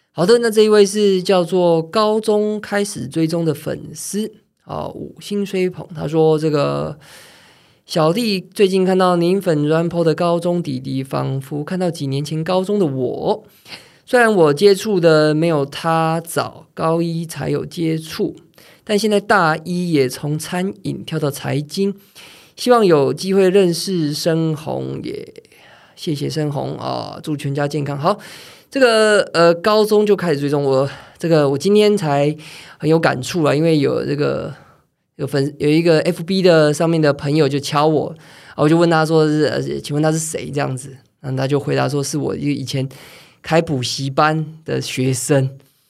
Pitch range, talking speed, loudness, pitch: 145-185 Hz, 245 characters per minute, -17 LUFS, 160 Hz